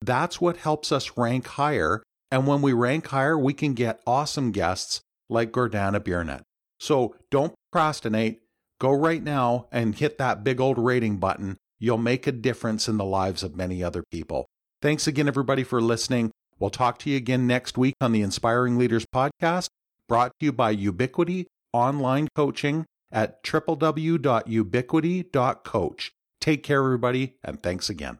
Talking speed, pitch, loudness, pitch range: 160 wpm, 125 Hz, -25 LUFS, 110-145 Hz